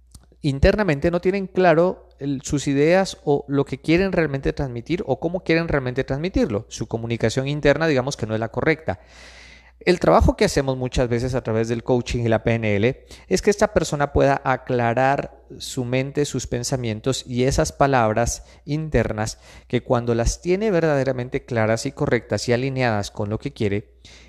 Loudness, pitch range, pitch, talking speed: -21 LUFS, 115-150 Hz, 130 Hz, 165 wpm